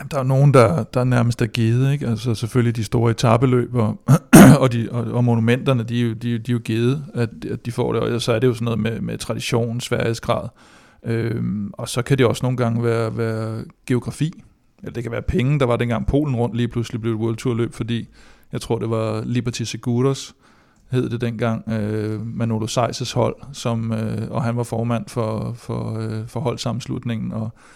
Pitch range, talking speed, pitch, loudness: 115-125 Hz, 205 wpm, 120 Hz, -20 LUFS